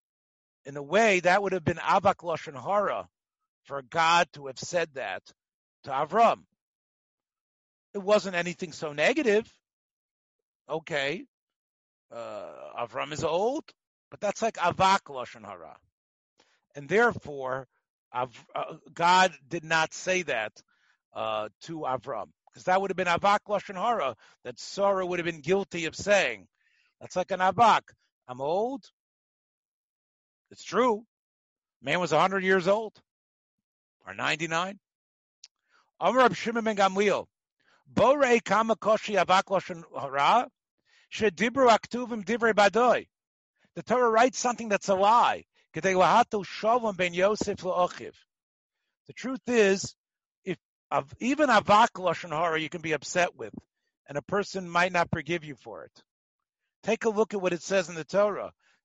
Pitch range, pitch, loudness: 165-215 Hz, 190 Hz, -26 LUFS